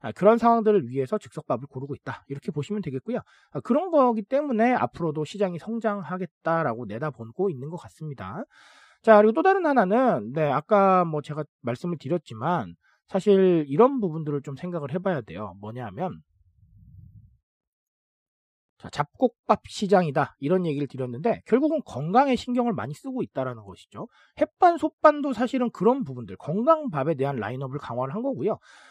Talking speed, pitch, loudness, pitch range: 350 characters per minute, 175 Hz, -24 LUFS, 135-225 Hz